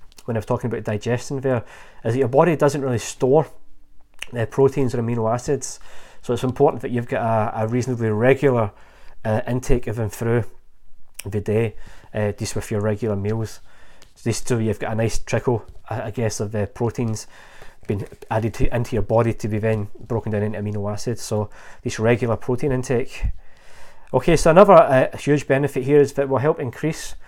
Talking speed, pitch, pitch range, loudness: 195 wpm, 115 Hz, 110-130 Hz, -21 LUFS